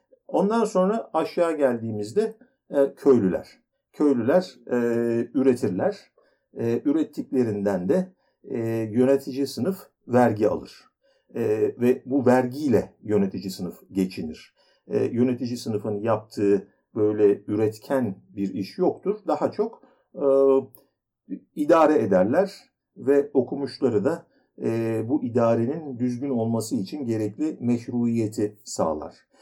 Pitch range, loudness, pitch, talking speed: 110-155 Hz, -24 LUFS, 125 Hz, 100 wpm